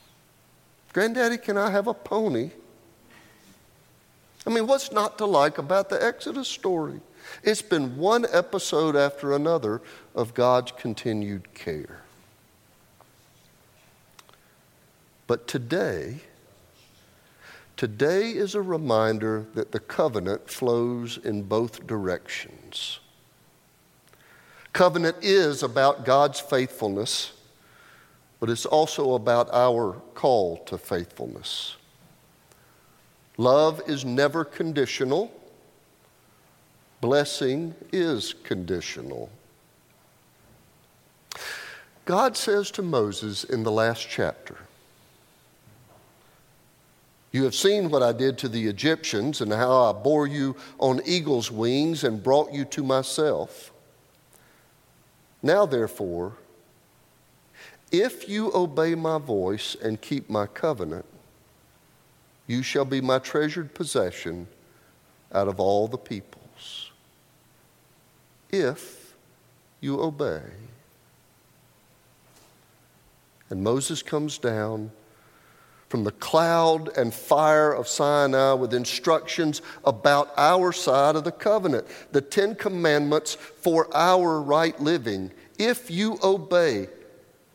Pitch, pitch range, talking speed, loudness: 140 Hz, 120-165 Hz, 100 wpm, -25 LUFS